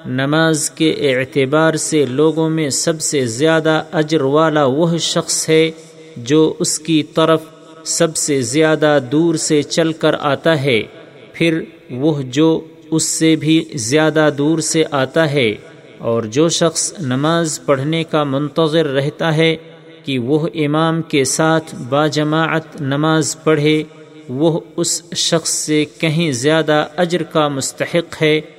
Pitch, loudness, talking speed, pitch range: 155 Hz, -15 LUFS, 140 wpm, 150-160 Hz